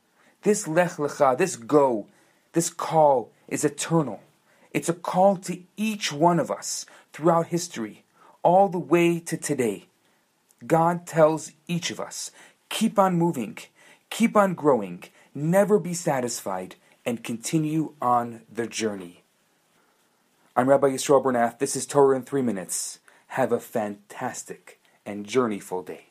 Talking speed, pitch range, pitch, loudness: 135 wpm, 125-175 Hz, 155 Hz, -24 LUFS